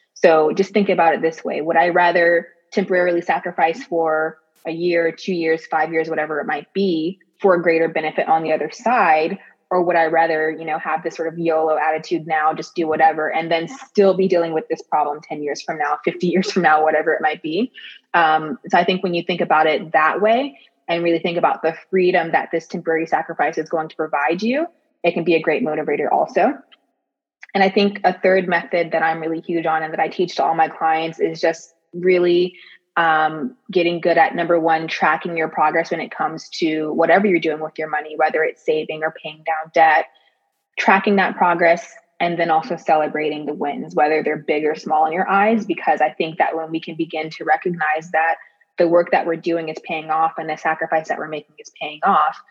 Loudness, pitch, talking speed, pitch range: -19 LUFS, 165 Hz, 220 wpm, 155-180 Hz